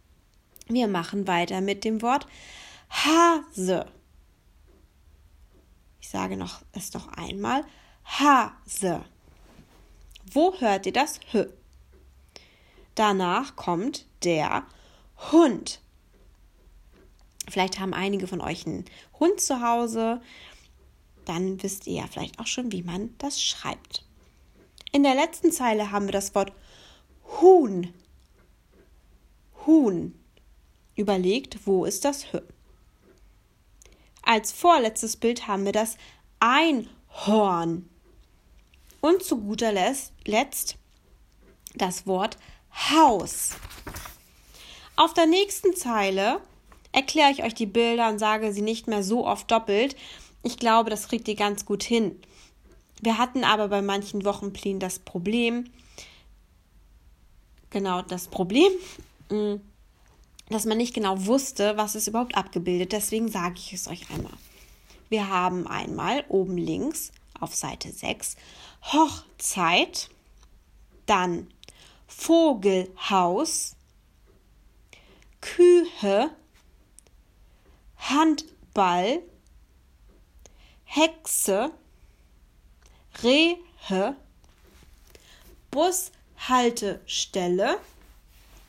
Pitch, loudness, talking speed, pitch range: 205 Hz, -25 LUFS, 95 wpm, 175-255 Hz